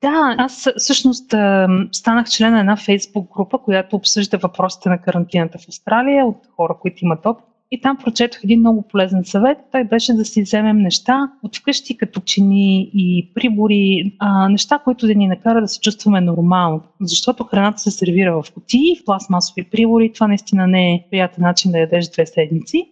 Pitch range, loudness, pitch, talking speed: 185-230 Hz, -16 LUFS, 205 Hz, 180 wpm